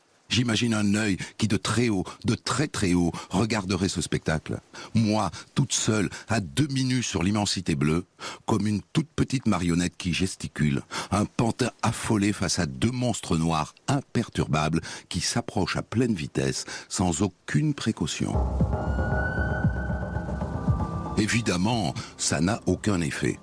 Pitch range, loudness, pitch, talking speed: 85-115 Hz, -26 LUFS, 105 Hz, 135 wpm